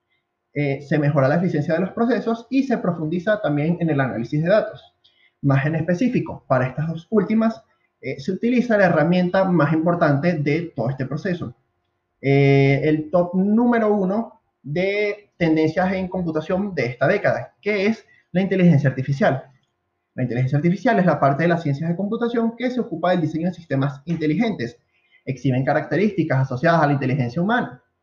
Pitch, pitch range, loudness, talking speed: 165 Hz, 140-195 Hz, -20 LUFS, 165 wpm